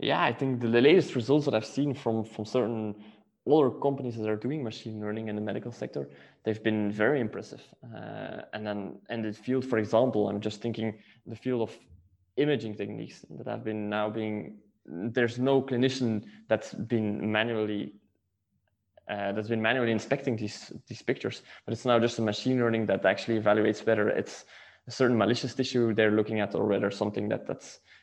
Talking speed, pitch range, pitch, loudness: 185 wpm, 105-120 Hz, 110 Hz, -29 LUFS